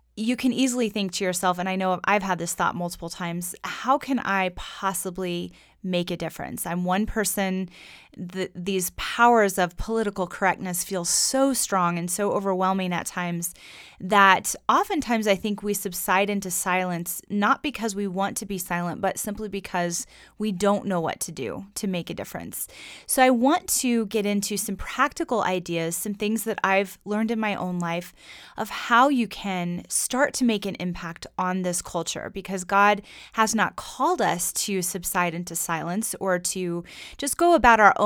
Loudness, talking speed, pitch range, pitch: -24 LUFS, 180 wpm, 180-215 Hz, 195 Hz